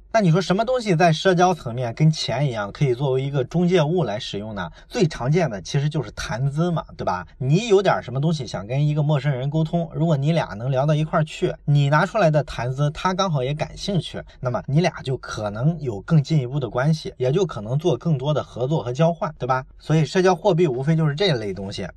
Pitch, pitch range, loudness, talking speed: 155 Hz, 135-170 Hz, -22 LUFS, 345 characters per minute